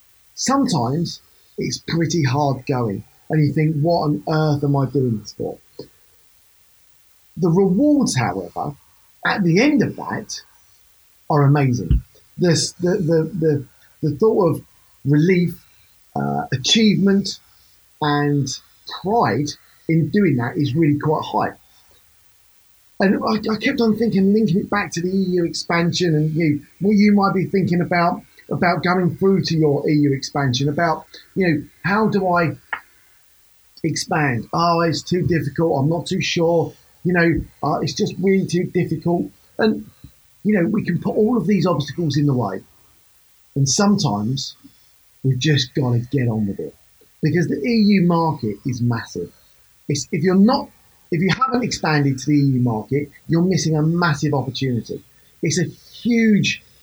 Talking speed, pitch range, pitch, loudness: 155 wpm, 135-180 Hz, 155 Hz, -19 LUFS